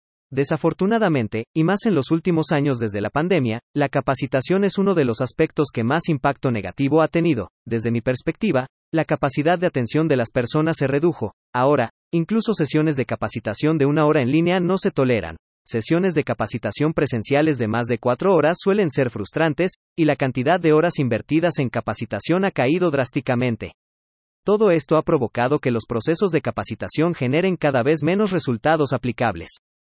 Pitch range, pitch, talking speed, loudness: 120-160 Hz, 145 Hz, 175 wpm, -21 LUFS